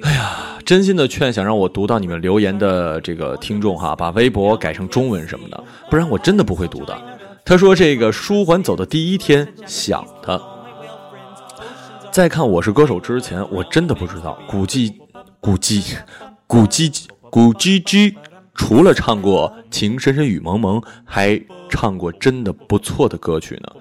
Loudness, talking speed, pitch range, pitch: -16 LUFS, 240 characters per minute, 100-160 Hz, 115 Hz